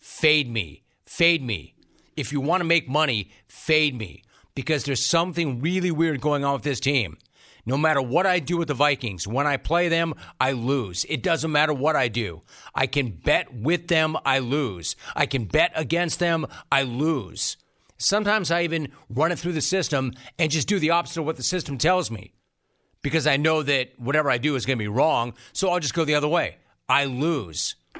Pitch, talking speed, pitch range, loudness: 145 Hz, 205 wpm, 125-165 Hz, -23 LUFS